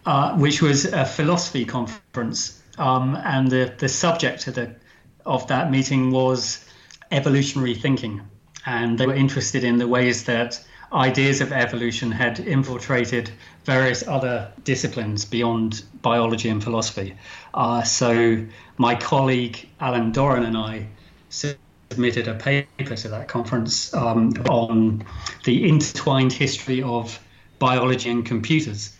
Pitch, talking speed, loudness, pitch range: 125 Hz, 130 wpm, -21 LUFS, 115-135 Hz